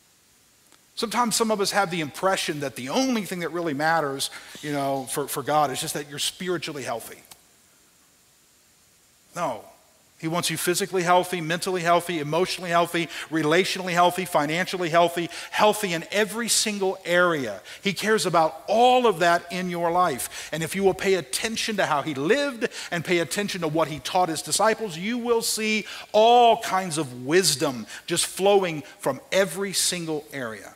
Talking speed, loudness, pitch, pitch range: 165 wpm, -24 LUFS, 180 Hz, 160-200 Hz